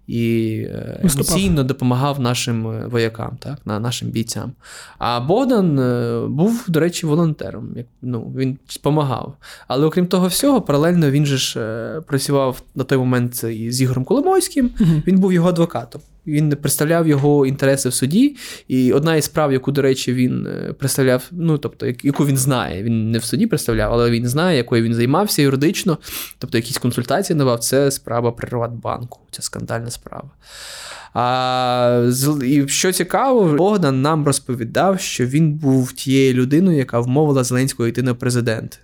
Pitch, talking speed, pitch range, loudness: 135 Hz, 155 wpm, 120-155 Hz, -18 LUFS